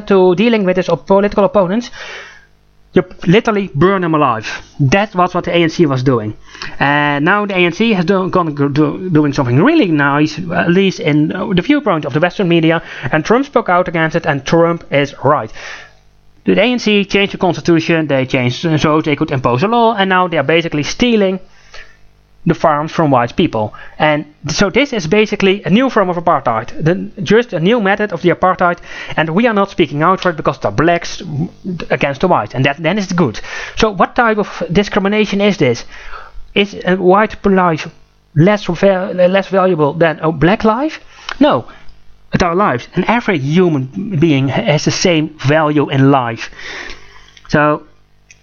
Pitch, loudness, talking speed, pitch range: 175 Hz, -13 LUFS, 180 wpm, 155-195 Hz